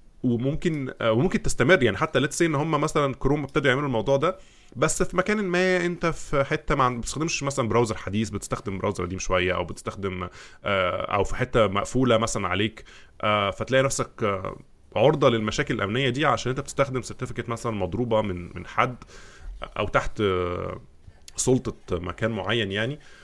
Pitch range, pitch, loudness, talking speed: 100-140 Hz, 120 Hz, -25 LUFS, 150 wpm